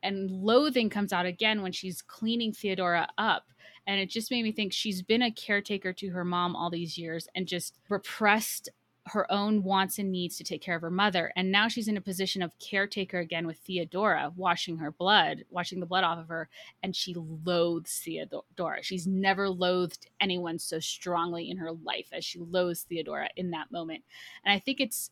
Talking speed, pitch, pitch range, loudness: 200 wpm, 185 Hz, 170-200 Hz, -30 LUFS